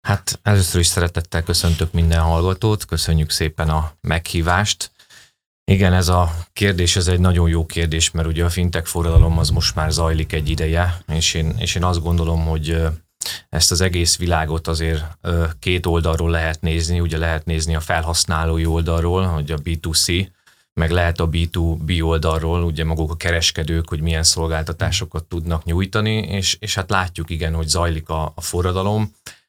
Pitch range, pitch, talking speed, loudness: 80-90 Hz, 85 Hz, 165 wpm, -19 LUFS